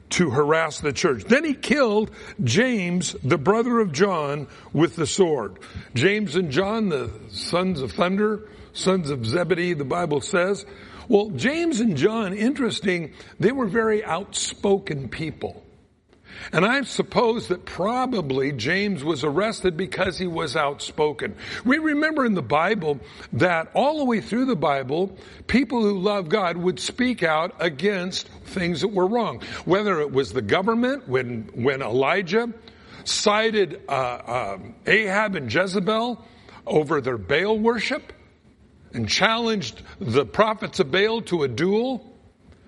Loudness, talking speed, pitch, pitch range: -23 LUFS, 140 wpm, 190 Hz, 160-225 Hz